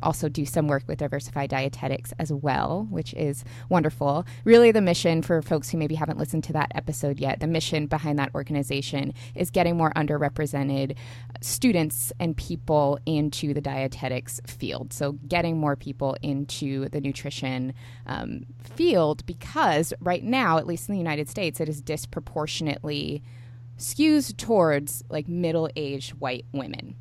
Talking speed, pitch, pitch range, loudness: 150 wpm, 145 Hz, 135-160 Hz, -26 LUFS